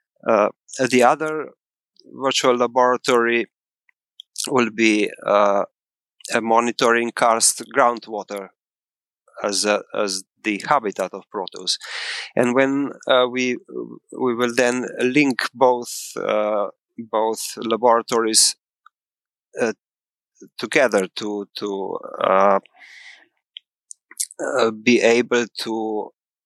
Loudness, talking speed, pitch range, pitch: -20 LUFS, 90 wpm, 105-125 Hz, 115 Hz